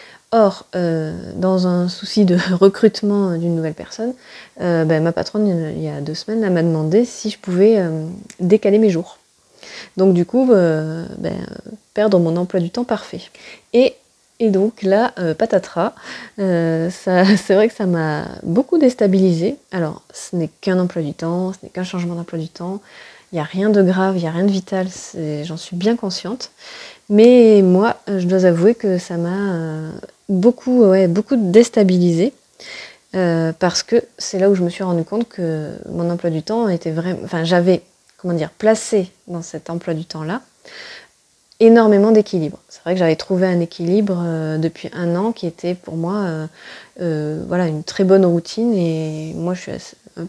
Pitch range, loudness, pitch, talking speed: 170-210 Hz, -17 LUFS, 185 Hz, 185 wpm